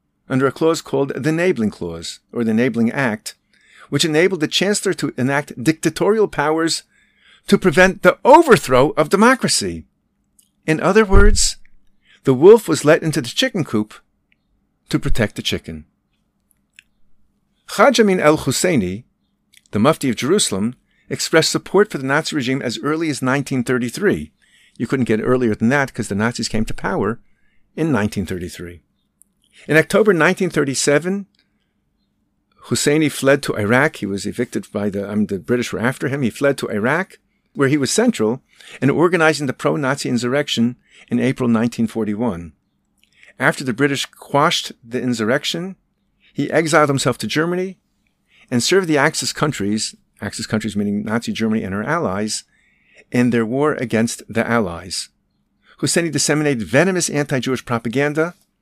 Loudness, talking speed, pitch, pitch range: -18 LUFS, 145 wpm, 135 Hz, 115-155 Hz